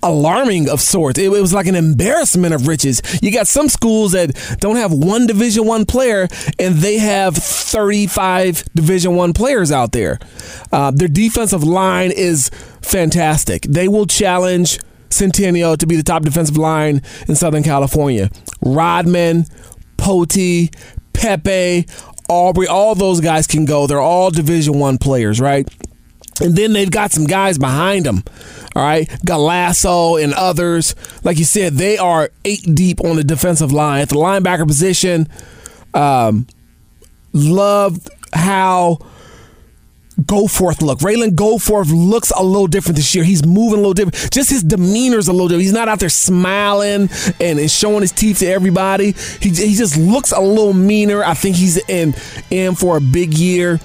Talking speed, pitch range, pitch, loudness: 160 wpm, 155-195 Hz, 180 Hz, -13 LUFS